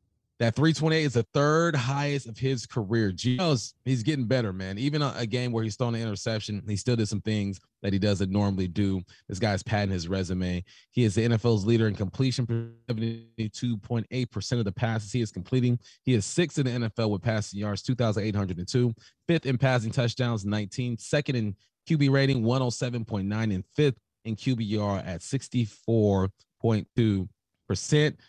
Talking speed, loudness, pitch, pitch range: 170 wpm, -28 LUFS, 115 Hz, 105-125 Hz